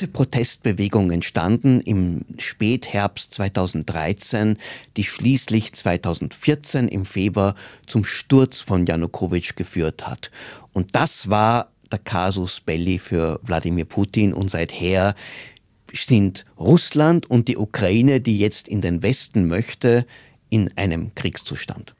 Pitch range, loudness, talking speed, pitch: 90-120 Hz, -21 LUFS, 110 wpm, 105 Hz